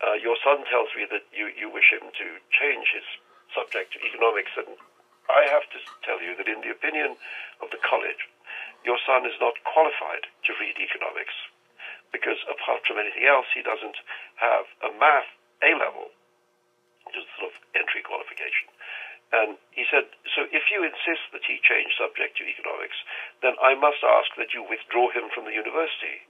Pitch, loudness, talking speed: 295 Hz, -24 LUFS, 180 wpm